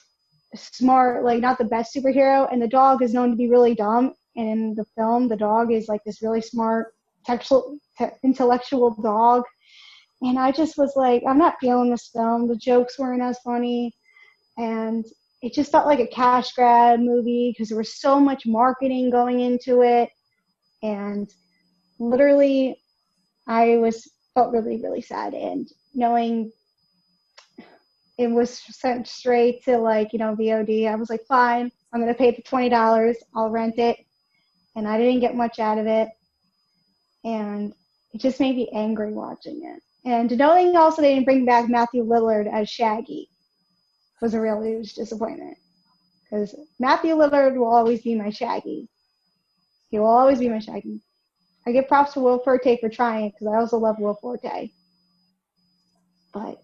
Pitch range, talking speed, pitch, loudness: 220-250 Hz, 165 wpm, 235 Hz, -21 LUFS